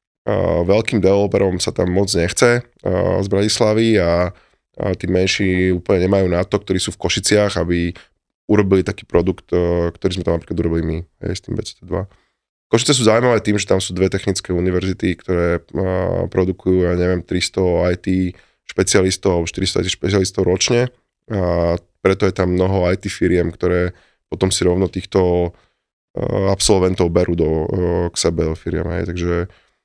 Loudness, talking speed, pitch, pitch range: -18 LUFS, 160 wpm, 90 Hz, 85-95 Hz